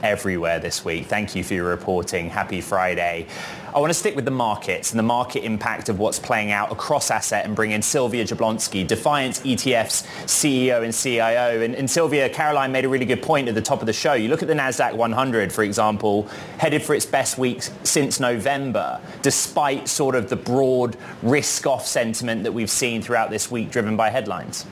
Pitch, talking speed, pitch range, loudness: 115 Hz, 200 wpm, 105-130 Hz, -21 LUFS